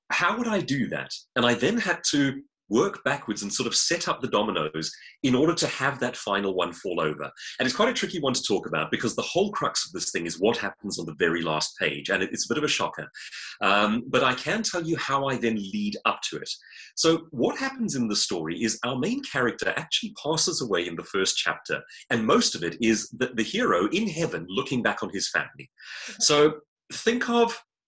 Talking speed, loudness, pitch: 230 wpm, -26 LUFS, 150 Hz